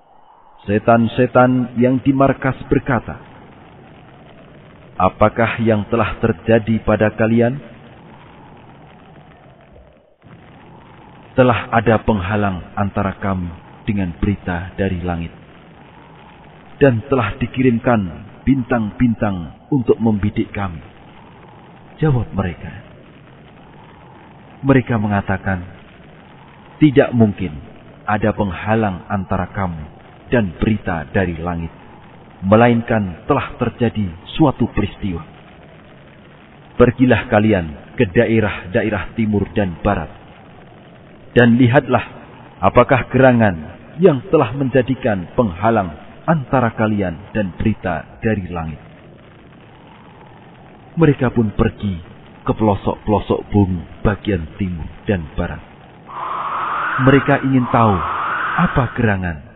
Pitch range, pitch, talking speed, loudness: 95-125 Hz, 110 Hz, 85 wpm, -17 LUFS